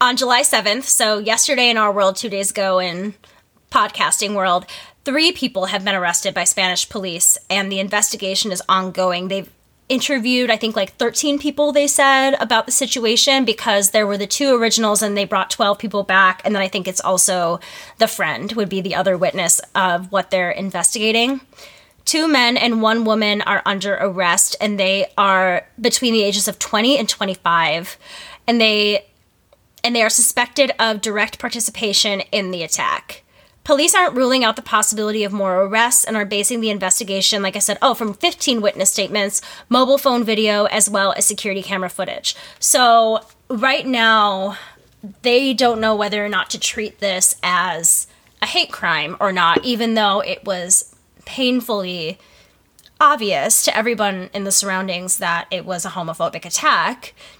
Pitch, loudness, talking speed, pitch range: 210 Hz, -16 LUFS, 170 wpm, 195-235 Hz